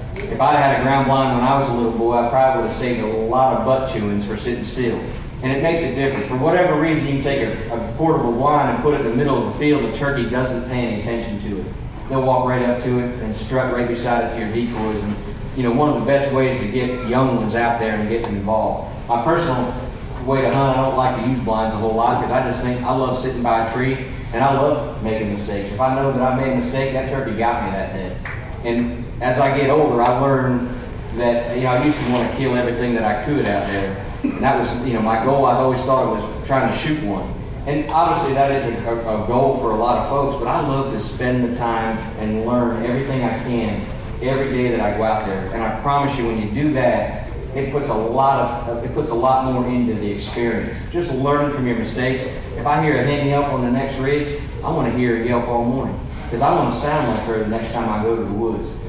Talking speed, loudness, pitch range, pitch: 265 wpm, -19 LUFS, 115-135 Hz, 125 Hz